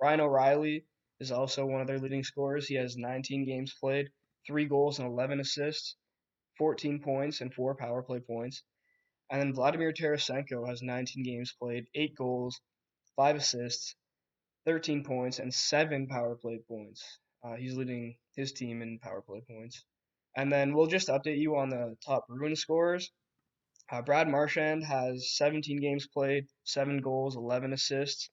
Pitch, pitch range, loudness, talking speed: 135 Hz, 125-145 Hz, -32 LUFS, 160 wpm